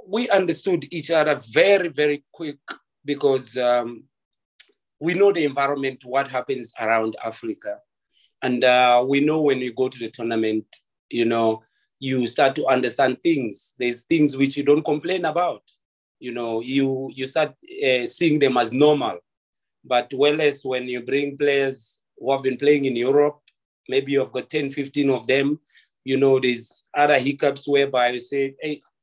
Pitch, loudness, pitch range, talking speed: 140 Hz, -21 LUFS, 125-150 Hz, 165 wpm